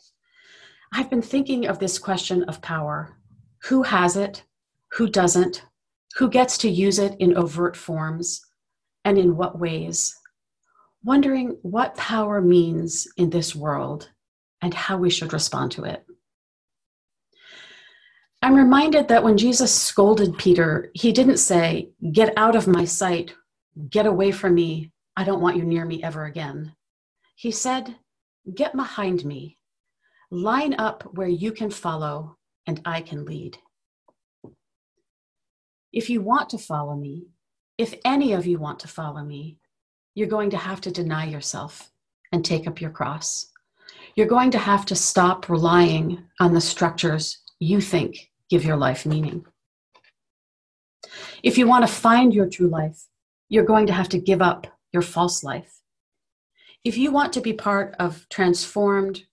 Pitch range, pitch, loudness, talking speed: 165-225 Hz, 180 Hz, -21 LUFS, 150 wpm